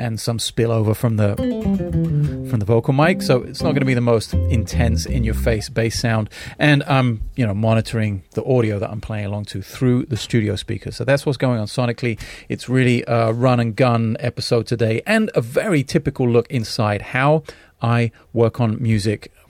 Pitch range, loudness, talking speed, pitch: 110-130 Hz, -19 LUFS, 190 wpm, 115 Hz